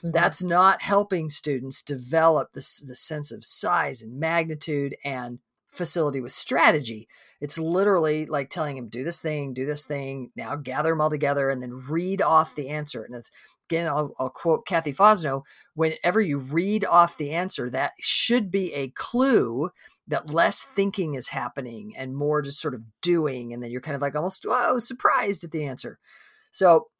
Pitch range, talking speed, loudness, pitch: 135-175 Hz, 180 wpm, -24 LUFS, 150 Hz